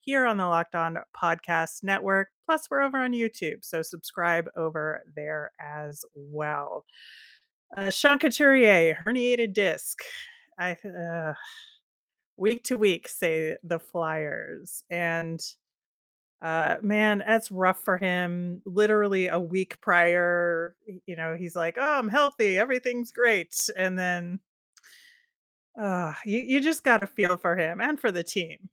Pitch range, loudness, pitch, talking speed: 170-235 Hz, -26 LUFS, 190 Hz, 140 wpm